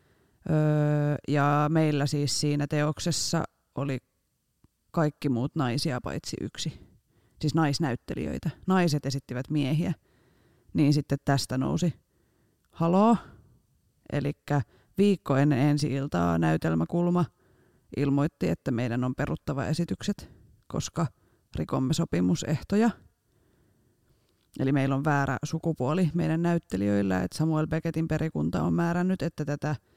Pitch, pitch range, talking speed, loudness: 145 Hz, 125-160 Hz, 100 wpm, -28 LUFS